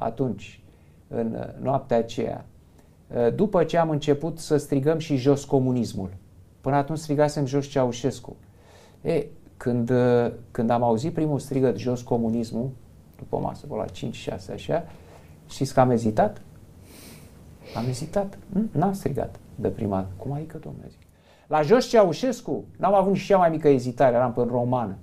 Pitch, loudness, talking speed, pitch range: 125 Hz, -24 LUFS, 150 wpm, 105-150 Hz